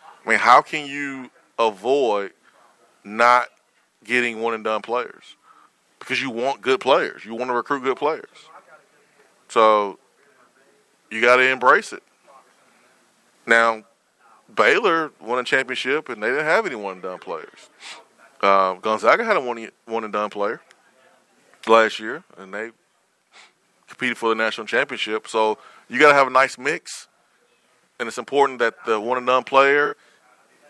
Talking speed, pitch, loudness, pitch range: 150 wpm, 115 Hz, -20 LUFS, 110-130 Hz